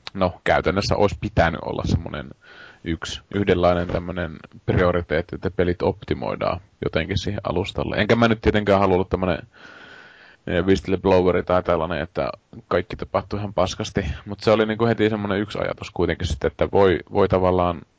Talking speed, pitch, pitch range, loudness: 145 wpm, 95 Hz, 90-105 Hz, -22 LUFS